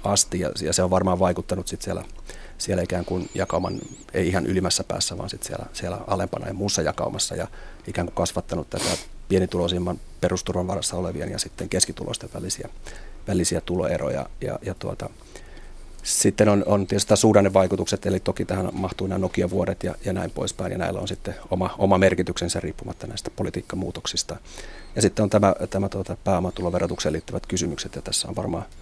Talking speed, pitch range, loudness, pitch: 170 wpm, 90-100 Hz, -24 LUFS, 95 Hz